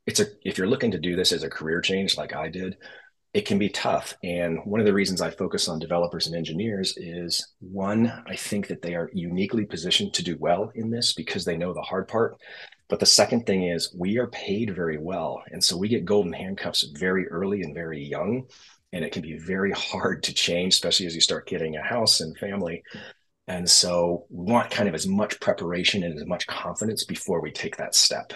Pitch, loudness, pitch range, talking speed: 90 Hz, -25 LUFS, 85-100 Hz, 225 wpm